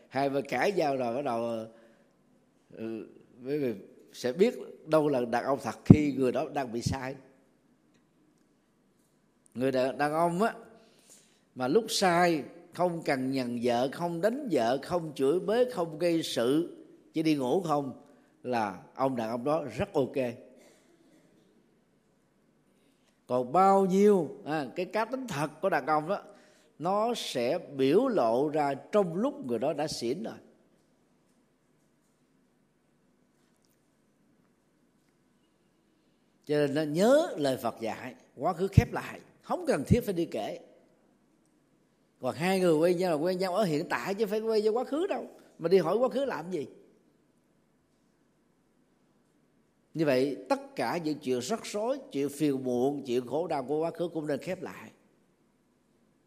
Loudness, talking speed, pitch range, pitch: -29 LUFS, 150 wpm, 135-200 Hz, 160 Hz